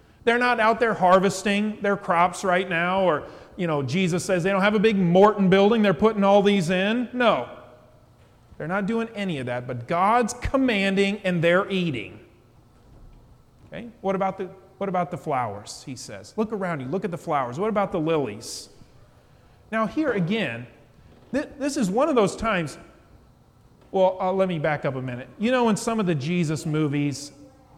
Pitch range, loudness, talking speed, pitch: 145-210 Hz, -23 LUFS, 185 wpm, 185 Hz